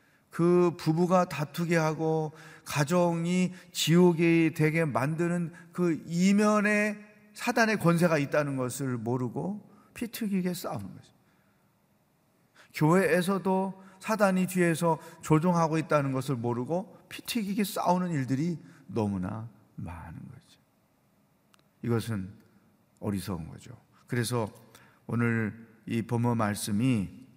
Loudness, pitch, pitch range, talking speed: -28 LUFS, 165 Hz, 125-180 Hz, 235 characters per minute